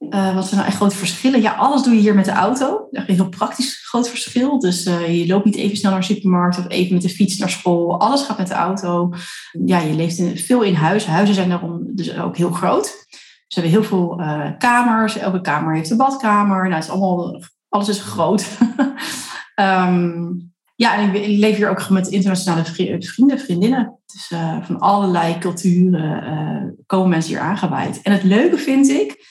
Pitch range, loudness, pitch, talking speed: 175-215 Hz, -17 LUFS, 190 Hz, 210 wpm